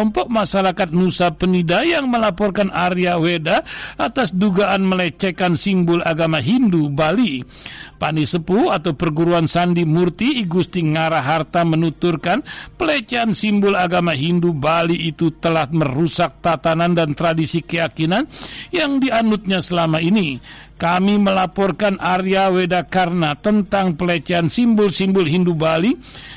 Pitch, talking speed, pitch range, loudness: 180 Hz, 110 wpm, 165-200 Hz, -17 LUFS